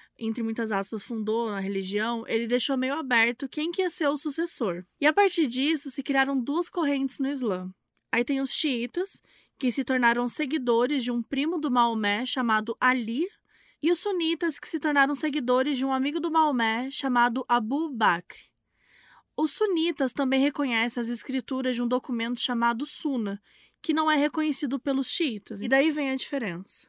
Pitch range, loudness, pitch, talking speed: 235-300 Hz, -26 LUFS, 270 Hz, 175 wpm